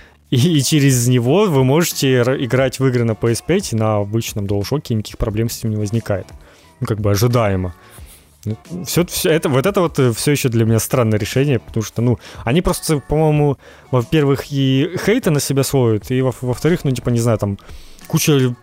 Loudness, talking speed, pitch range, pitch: -17 LUFS, 185 wpm, 110-140 Hz, 125 Hz